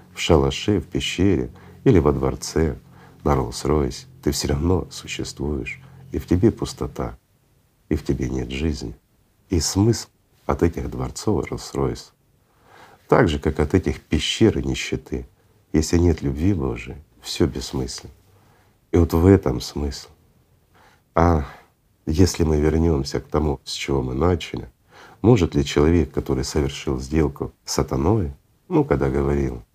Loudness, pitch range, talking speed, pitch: -22 LUFS, 70-90 Hz, 135 wpm, 75 Hz